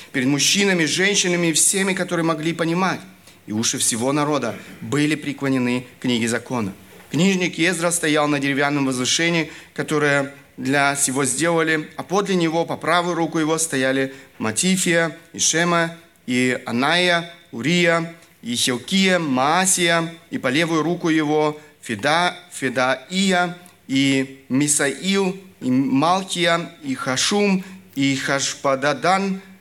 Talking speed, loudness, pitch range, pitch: 120 wpm, -20 LUFS, 140-175 Hz, 160 Hz